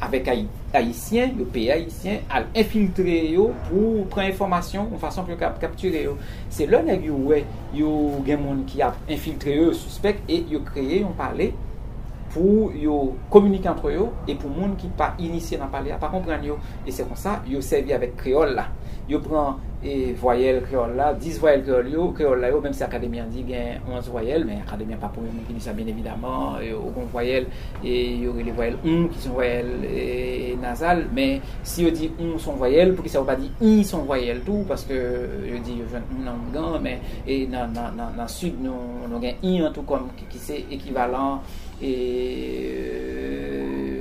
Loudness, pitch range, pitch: -24 LUFS, 120-160 Hz, 130 Hz